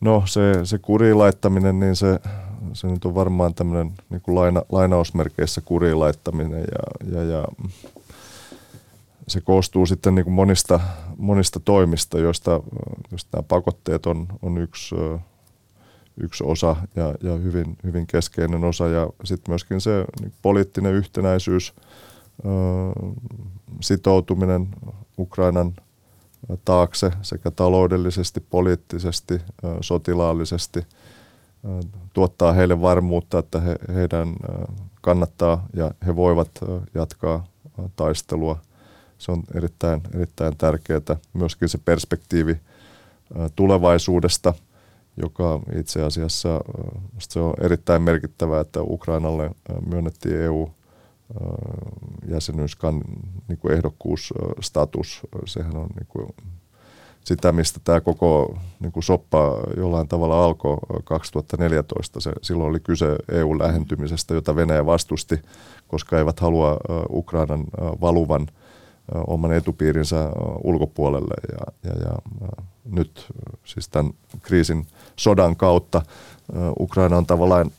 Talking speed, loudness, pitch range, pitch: 105 wpm, -22 LUFS, 85-95 Hz, 90 Hz